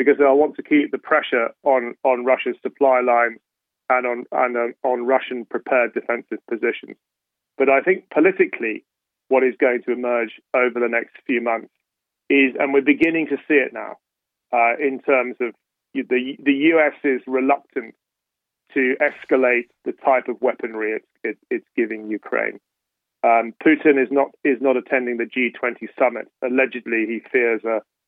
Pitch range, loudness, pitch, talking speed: 120-140 Hz, -20 LUFS, 130 Hz, 165 wpm